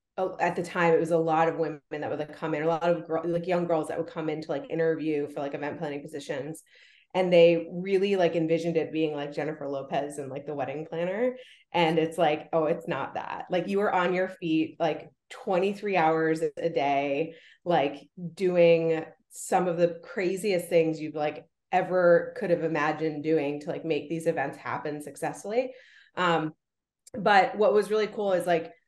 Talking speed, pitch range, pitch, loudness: 195 wpm, 155-175 Hz, 165 Hz, -27 LUFS